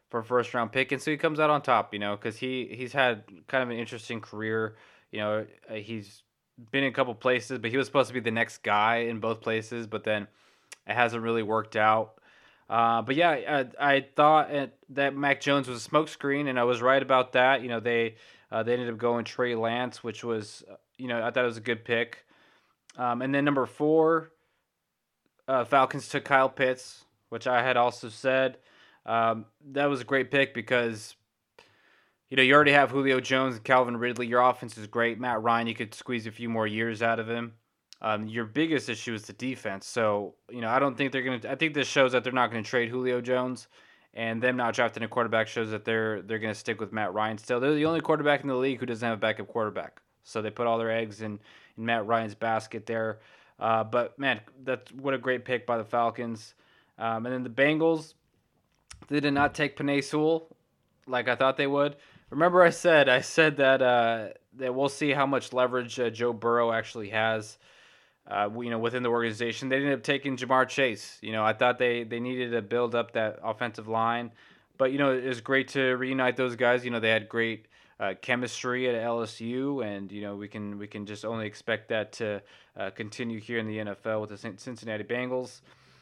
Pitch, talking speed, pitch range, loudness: 120 Hz, 225 wpm, 115-130 Hz, -27 LUFS